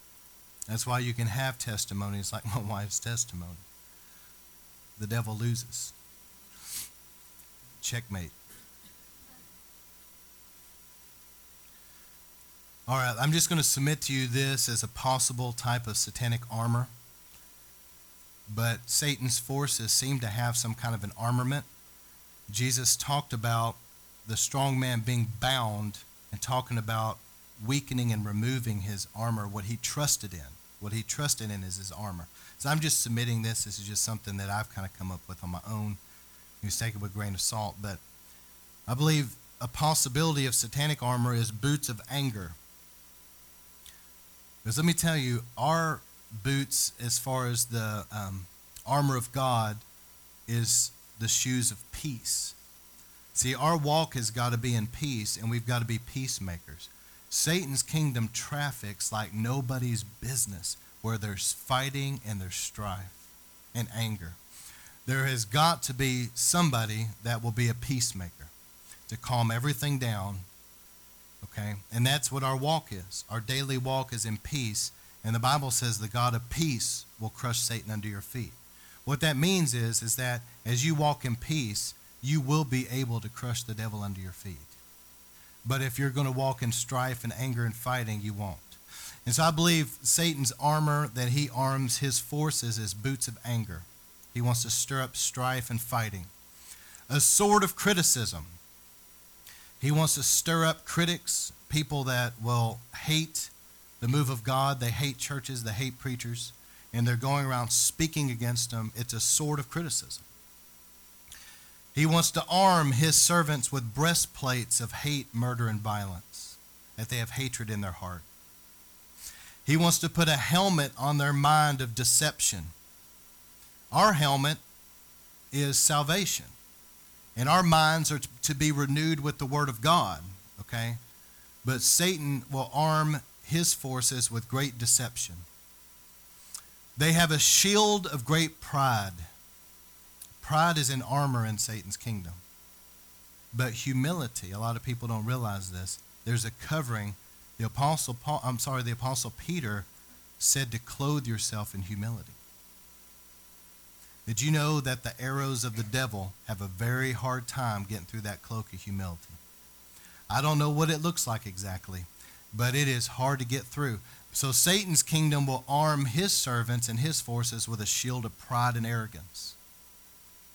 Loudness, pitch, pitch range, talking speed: -29 LUFS, 115 Hz, 90-135 Hz, 155 wpm